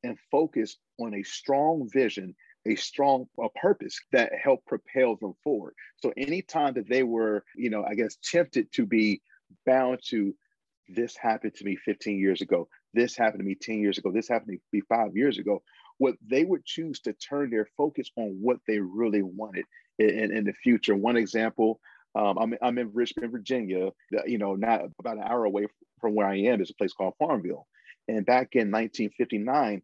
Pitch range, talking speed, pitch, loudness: 100-120 Hz, 190 wpm, 110 Hz, -28 LUFS